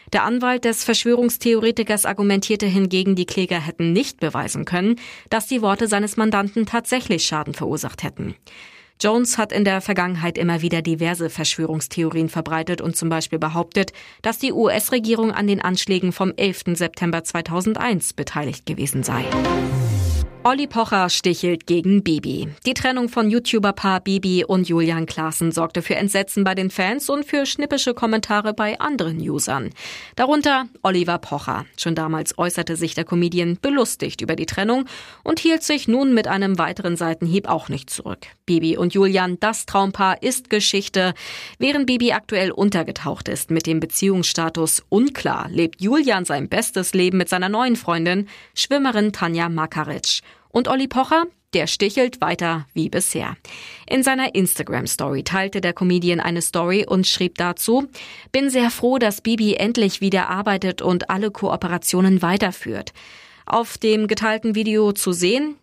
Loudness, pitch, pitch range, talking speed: -20 LUFS, 190 Hz, 170-225 Hz, 150 wpm